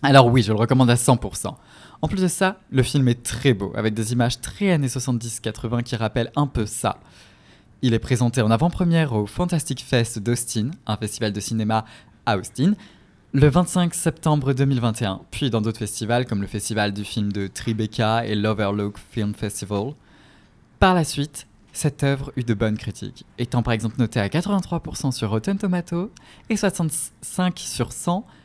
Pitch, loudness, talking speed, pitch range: 120 Hz, -22 LUFS, 175 wpm, 110-150 Hz